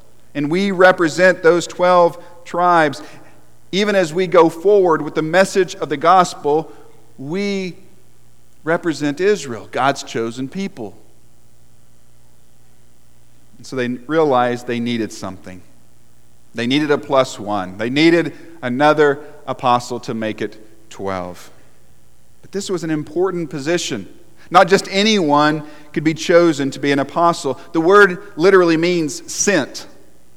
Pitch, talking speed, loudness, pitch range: 150 Hz, 125 wpm, -16 LUFS, 110-175 Hz